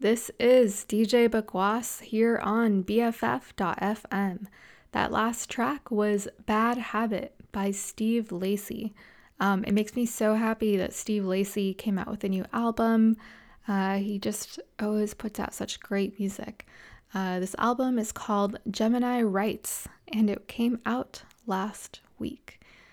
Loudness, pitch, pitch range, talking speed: -28 LUFS, 215 Hz, 200-230 Hz, 140 wpm